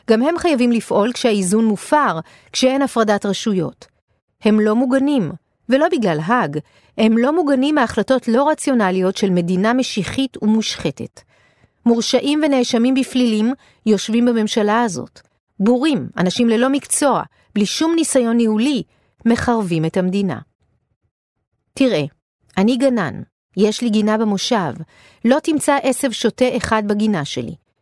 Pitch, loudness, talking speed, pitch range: 230 Hz, -17 LUFS, 120 wpm, 200-260 Hz